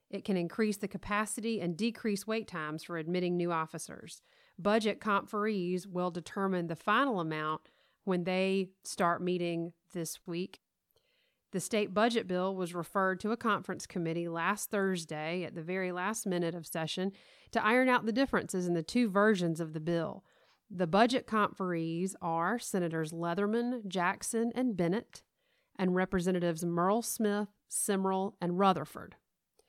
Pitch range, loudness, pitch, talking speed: 175-215 Hz, -33 LUFS, 190 Hz, 150 wpm